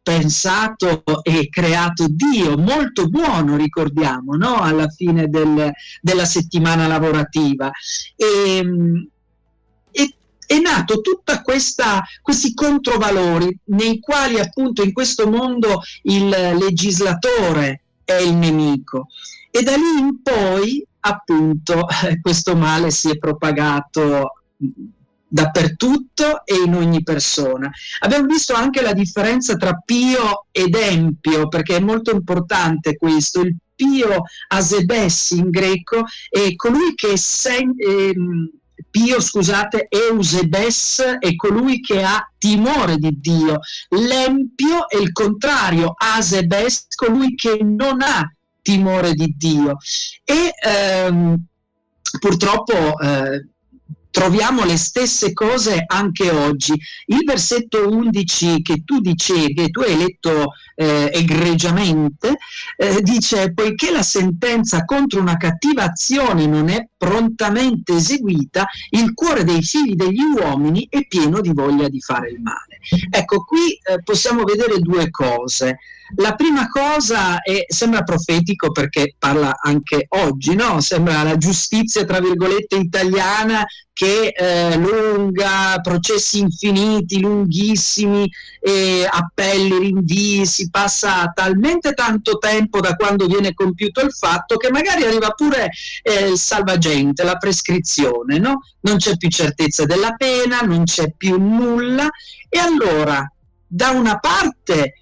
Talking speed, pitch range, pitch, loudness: 120 wpm, 165-225 Hz, 190 Hz, -16 LUFS